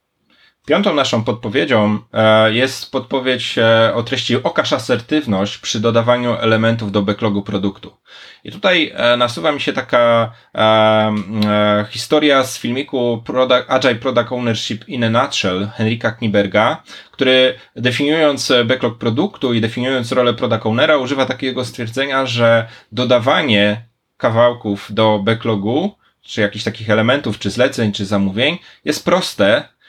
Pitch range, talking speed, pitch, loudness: 110-130 Hz, 120 wpm, 115 Hz, -16 LUFS